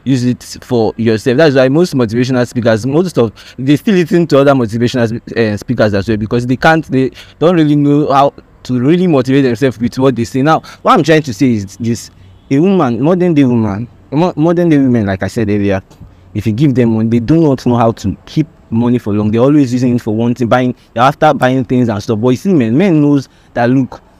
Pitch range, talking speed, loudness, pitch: 115-145 Hz, 230 wpm, -12 LUFS, 125 Hz